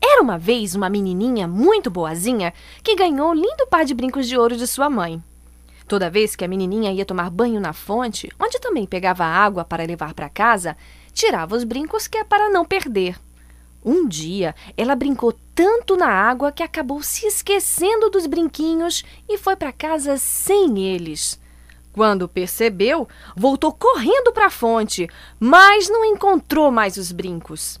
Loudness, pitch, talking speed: -18 LUFS, 235 Hz, 165 wpm